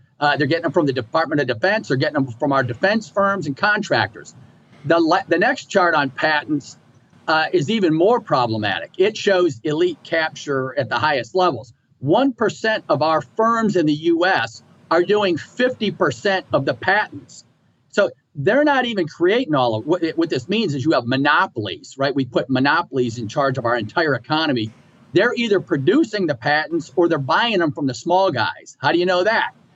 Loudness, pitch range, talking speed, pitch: -19 LUFS, 140-195 Hz, 195 wpm, 165 Hz